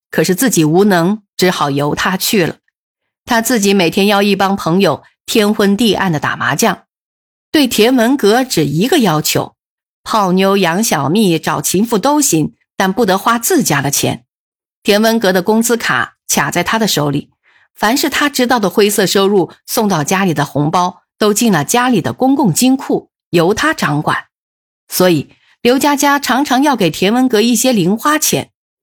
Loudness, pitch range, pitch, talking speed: -13 LUFS, 180-240 Hz, 200 Hz, 250 characters per minute